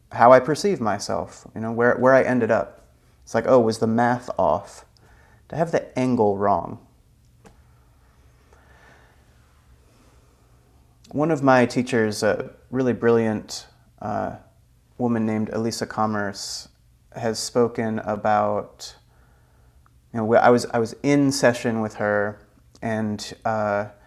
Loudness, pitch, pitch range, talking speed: -22 LUFS, 110 Hz, 95-120 Hz, 125 wpm